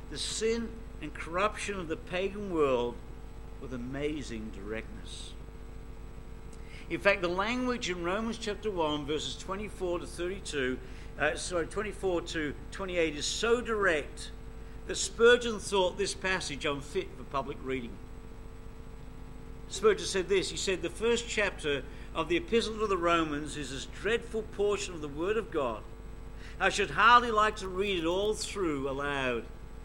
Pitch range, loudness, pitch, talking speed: 140-205 Hz, -31 LUFS, 175 Hz, 145 wpm